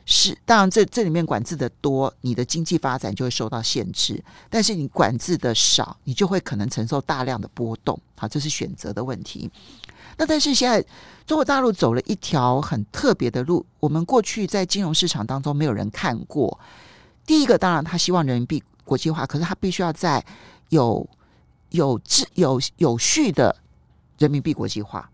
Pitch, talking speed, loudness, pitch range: 150 Hz, 290 characters per minute, -21 LUFS, 120-180 Hz